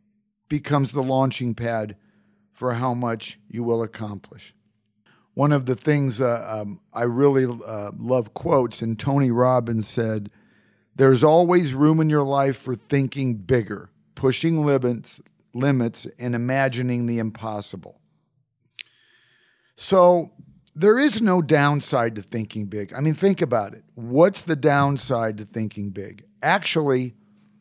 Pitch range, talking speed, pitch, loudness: 110-145 Hz, 135 wpm, 125 Hz, -22 LUFS